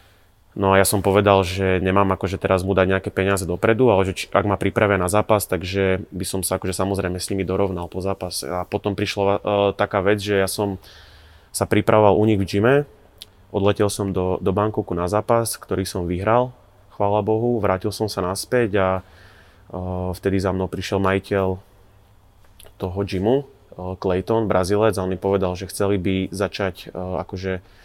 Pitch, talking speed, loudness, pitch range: 95 Hz, 185 wpm, -21 LUFS, 95-105 Hz